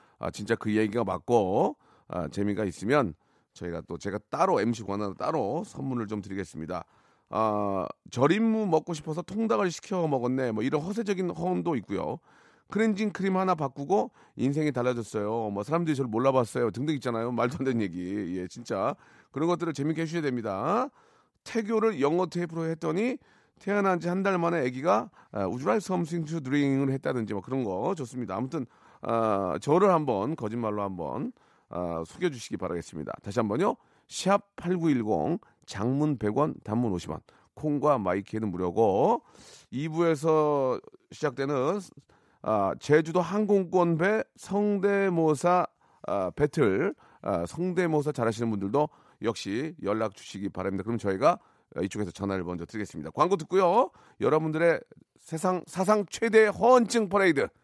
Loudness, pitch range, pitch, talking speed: -28 LUFS, 105-180 Hz, 140 Hz, 325 characters per minute